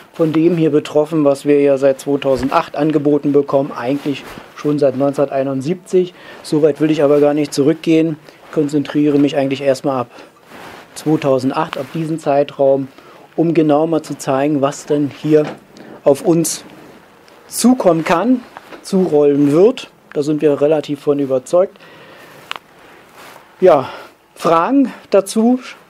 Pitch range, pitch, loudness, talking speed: 140-165 Hz, 150 Hz, -15 LUFS, 125 wpm